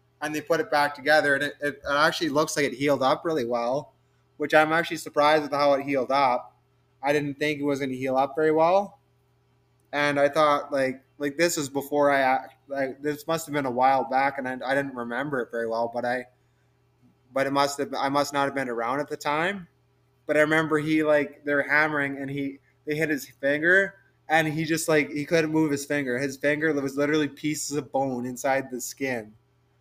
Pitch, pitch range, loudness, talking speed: 140 Hz, 130-150 Hz, -25 LUFS, 220 wpm